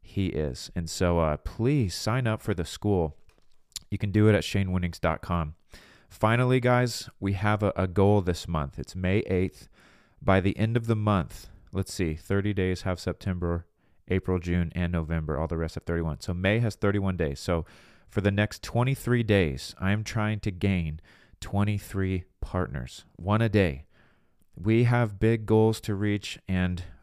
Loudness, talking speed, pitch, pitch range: -27 LUFS, 170 wpm, 95 Hz, 85-105 Hz